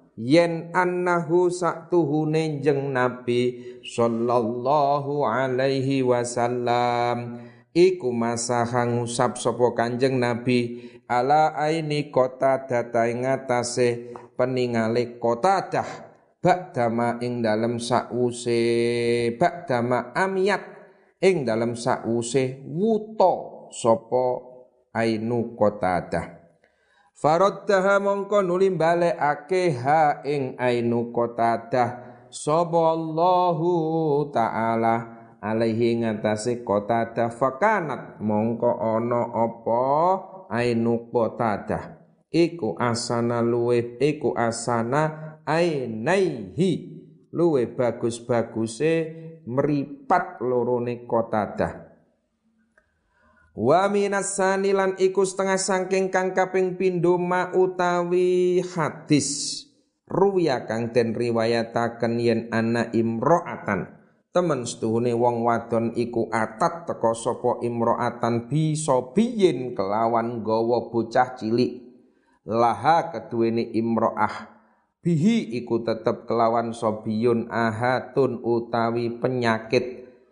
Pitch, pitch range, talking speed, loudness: 125 Hz, 115-165 Hz, 85 wpm, -23 LUFS